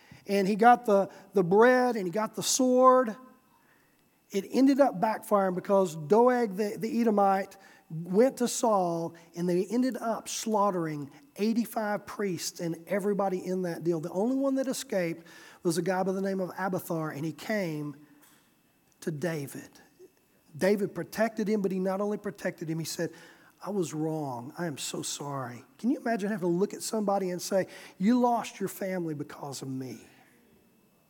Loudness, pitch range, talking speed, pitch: -29 LUFS, 170-220 Hz, 170 wpm, 195 Hz